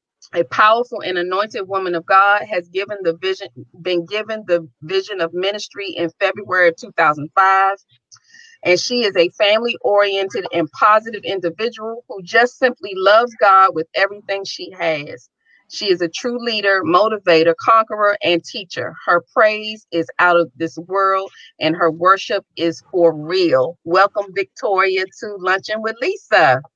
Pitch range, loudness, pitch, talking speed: 170-215 Hz, -17 LUFS, 195 Hz, 150 wpm